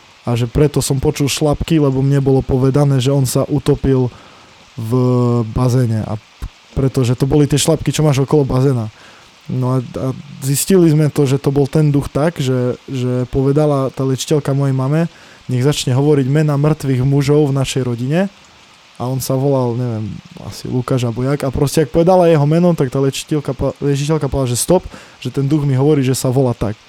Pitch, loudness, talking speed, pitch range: 135 Hz, -15 LUFS, 190 wpm, 125-145 Hz